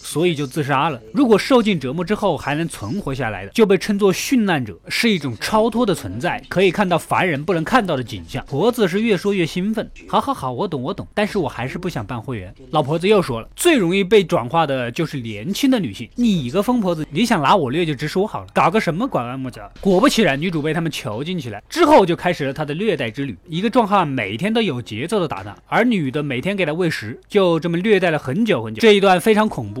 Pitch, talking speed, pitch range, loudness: 175 Hz, 365 characters per minute, 135-210 Hz, -19 LUFS